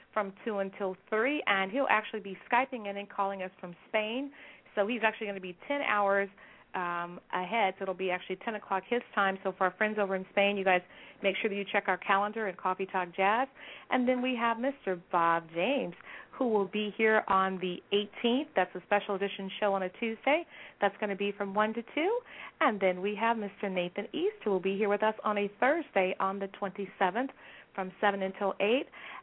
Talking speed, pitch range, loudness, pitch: 220 wpm, 190-230 Hz, -31 LUFS, 205 Hz